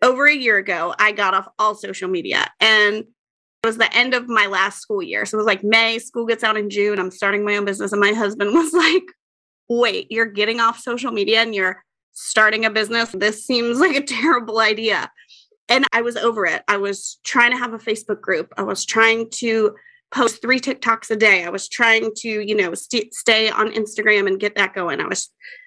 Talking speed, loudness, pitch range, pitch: 220 wpm, -18 LUFS, 210-240 Hz, 220 Hz